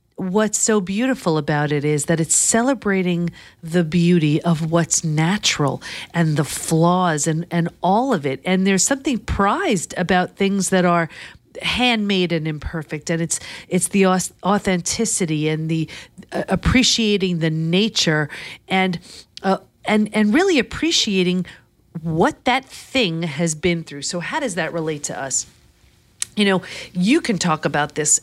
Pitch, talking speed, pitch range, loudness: 180 Hz, 145 wpm, 165-205 Hz, -19 LUFS